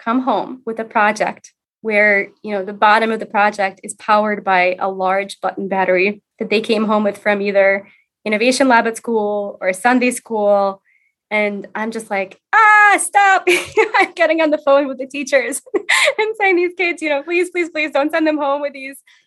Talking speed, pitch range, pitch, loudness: 195 wpm, 205-305 Hz, 225 Hz, -16 LUFS